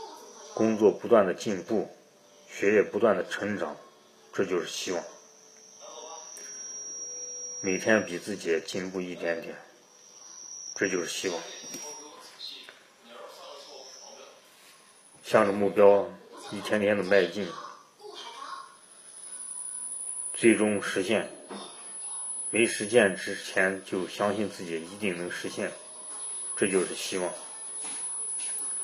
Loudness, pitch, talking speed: -28 LUFS, 105 Hz, 140 characters per minute